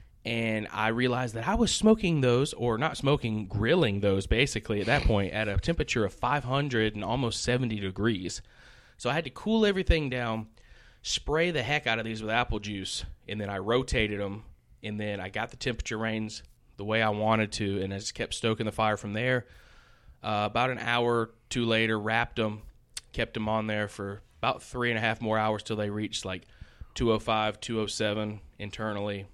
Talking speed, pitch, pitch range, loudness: 195 wpm, 110 Hz, 105-120 Hz, -29 LUFS